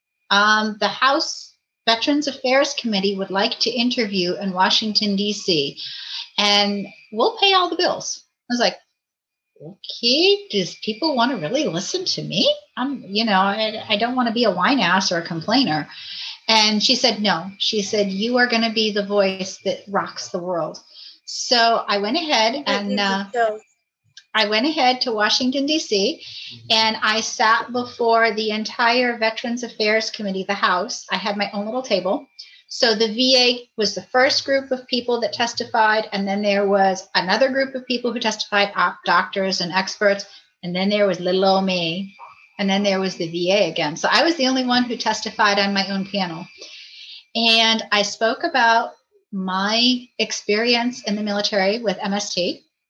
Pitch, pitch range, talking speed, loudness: 215 Hz, 200-245 Hz, 175 wpm, -19 LUFS